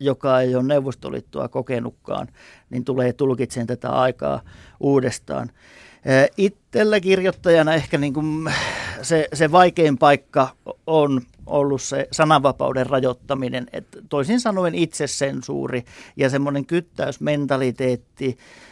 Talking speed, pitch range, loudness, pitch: 105 wpm, 130-160 Hz, -21 LUFS, 140 Hz